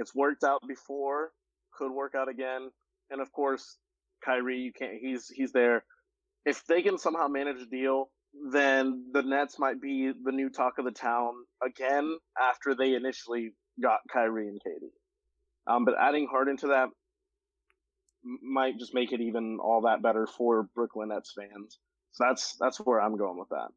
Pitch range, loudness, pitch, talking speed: 125-145 Hz, -30 LUFS, 135 Hz, 175 wpm